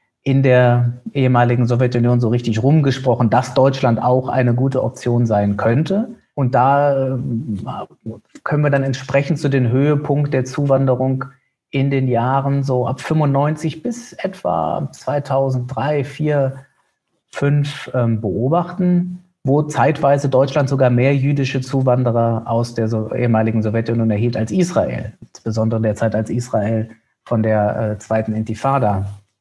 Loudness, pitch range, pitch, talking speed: -17 LUFS, 115-140 Hz, 130 Hz, 120 wpm